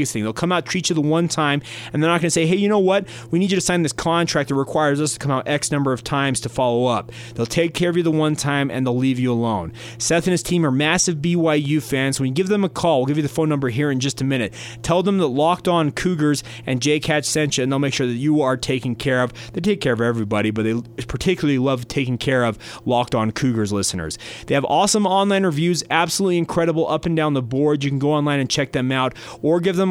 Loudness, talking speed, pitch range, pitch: -20 LUFS, 275 wpm, 125-165 Hz, 145 Hz